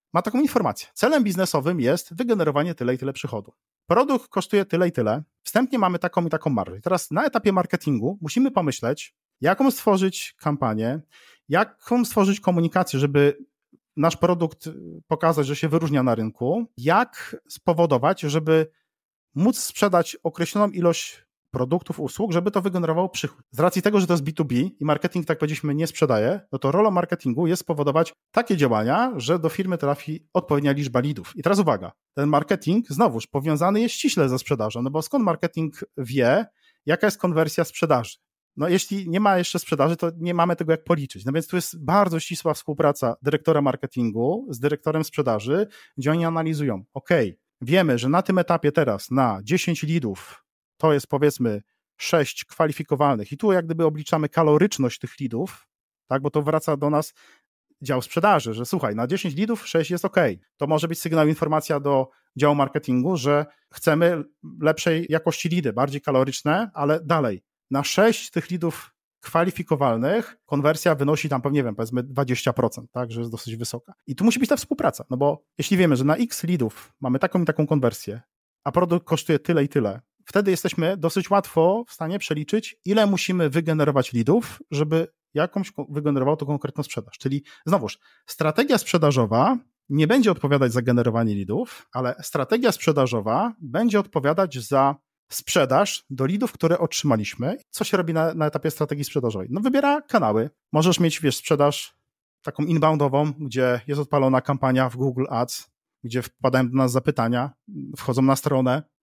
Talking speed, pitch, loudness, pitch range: 165 wpm, 155 Hz, -23 LUFS, 135-180 Hz